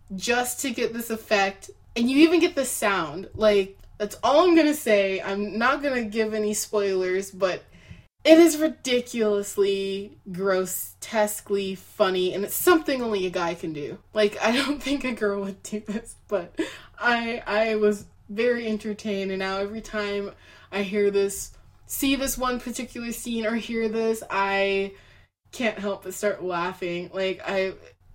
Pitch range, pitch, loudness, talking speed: 195-240 Hz, 210 Hz, -24 LUFS, 160 wpm